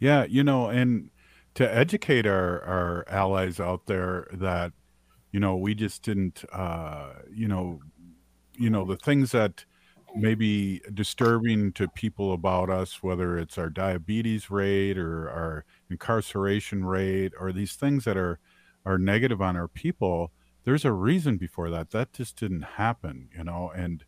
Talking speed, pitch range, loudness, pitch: 155 wpm, 85-110 Hz, -27 LUFS, 95 Hz